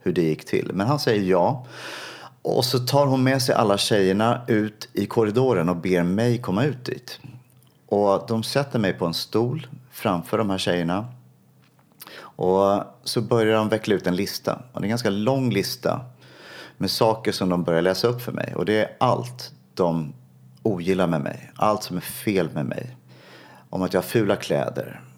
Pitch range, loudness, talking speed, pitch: 90-120 Hz, -23 LUFS, 190 wpm, 105 Hz